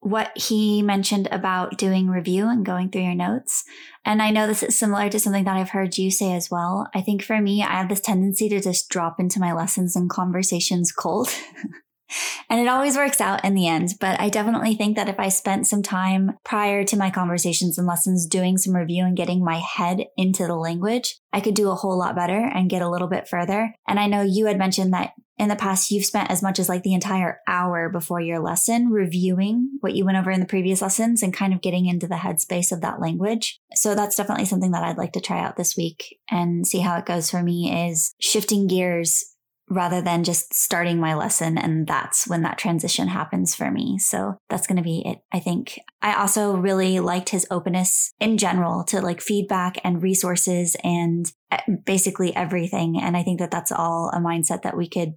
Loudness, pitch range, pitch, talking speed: -22 LUFS, 175-205 Hz, 190 Hz, 220 wpm